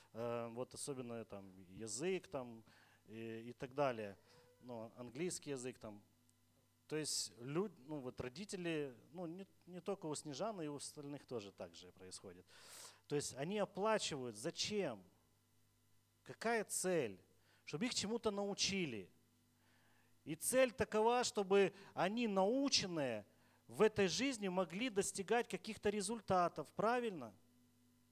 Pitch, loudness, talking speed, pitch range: 145 Hz, -41 LUFS, 125 wpm, 115-195 Hz